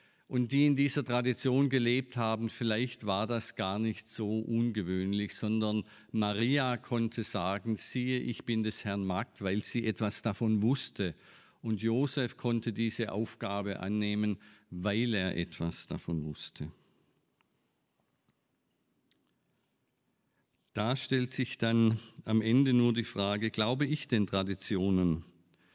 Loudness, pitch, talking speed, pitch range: -32 LUFS, 110 Hz, 125 wpm, 105-120 Hz